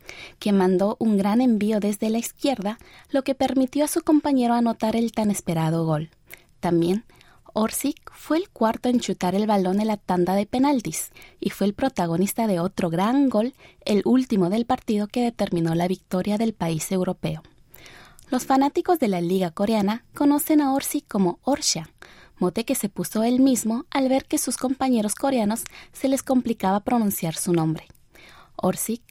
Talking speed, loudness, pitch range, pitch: 170 wpm, -23 LUFS, 185-260 Hz, 220 Hz